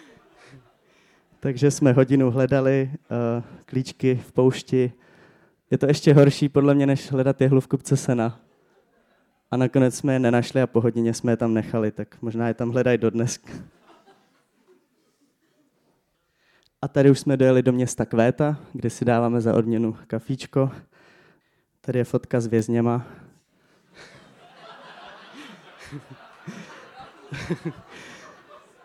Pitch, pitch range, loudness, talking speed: 130 Hz, 120-140 Hz, -22 LUFS, 120 wpm